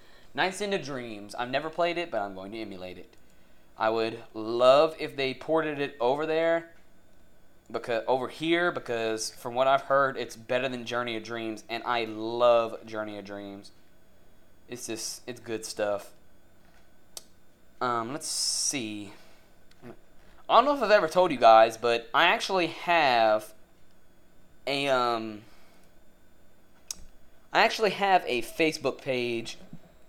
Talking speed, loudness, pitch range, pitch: 145 wpm, -27 LUFS, 110-150 Hz, 120 Hz